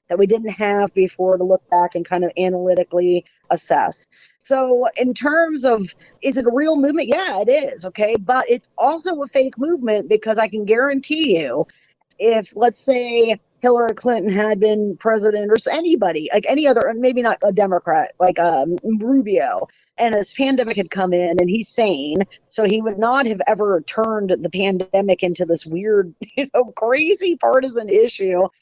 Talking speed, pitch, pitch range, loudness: 175 wpm, 220 Hz, 185-255 Hz, -18 LUFS